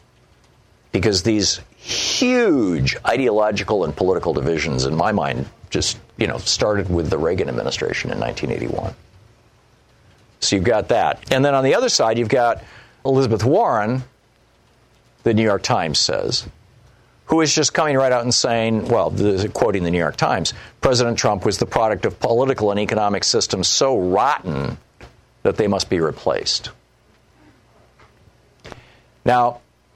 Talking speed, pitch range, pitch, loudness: 145 wpm, 105-125 Hz, 115 Hz, -19 LUFS